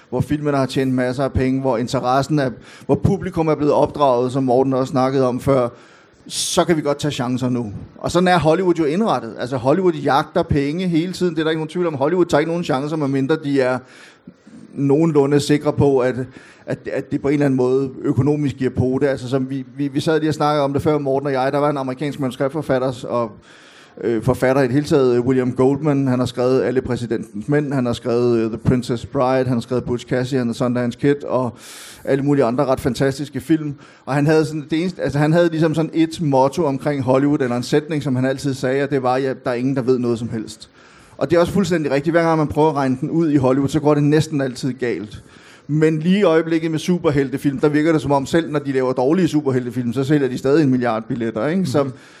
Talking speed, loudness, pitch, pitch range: 240 wpm, -19 LUFS, 140 Hz, 130-150 Hz